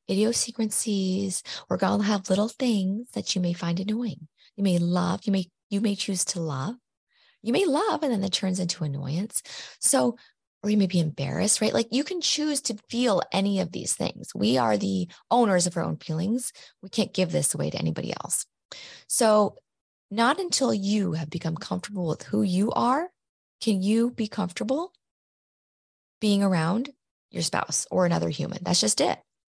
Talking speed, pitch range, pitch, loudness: 185 wpm, 180-225 Hz, 200 Hz, -26 LUFS